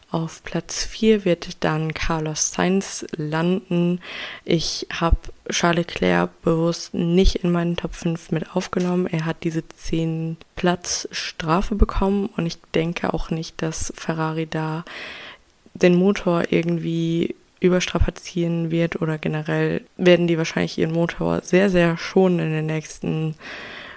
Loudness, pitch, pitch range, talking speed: -22 LUFS, 170 Hz, 160-180 Hz, 135 wpm